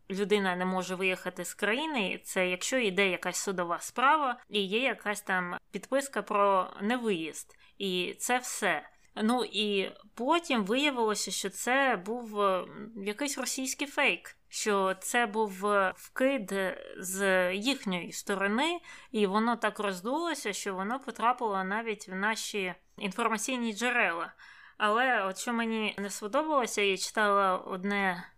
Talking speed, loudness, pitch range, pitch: 125 wpm, -30 LUFS, 190-240 Hz, 210 Hz